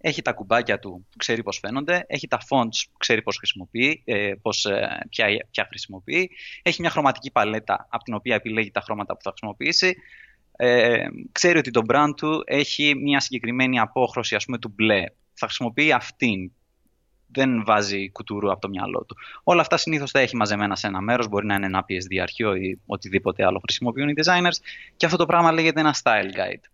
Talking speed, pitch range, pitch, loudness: 190 wpm, 105-145 Hz, 120 Hz, -22 LUFS